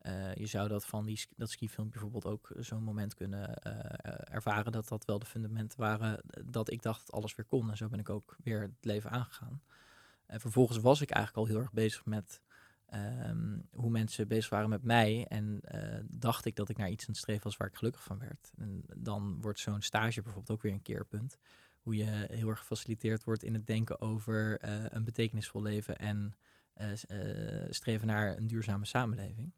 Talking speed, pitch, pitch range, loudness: 210 wpm, 110 Hz, 105-115 Hz, -37 LUFS